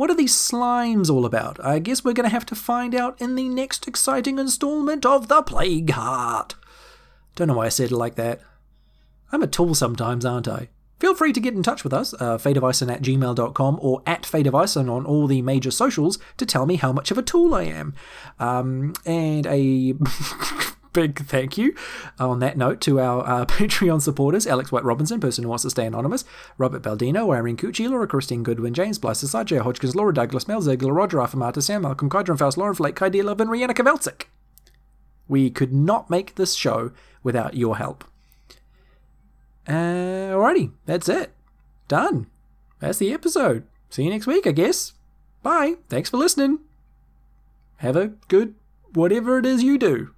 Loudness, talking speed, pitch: -22 LUFS, 180 wpm, 160 Hz